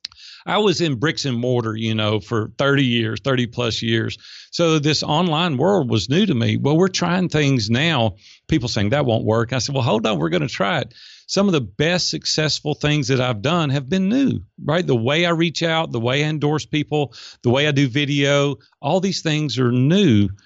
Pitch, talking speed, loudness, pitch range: 140 Hz, 220 wpm, -19 LUFS, 120-160 Hz